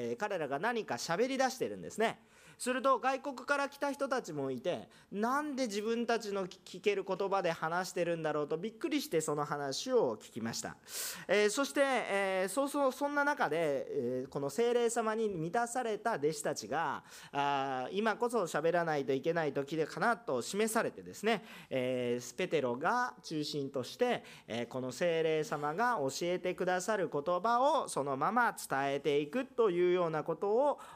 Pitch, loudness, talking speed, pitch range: 195 Hz, -34 LUFS, 335 characters per minute, 150-240 Hz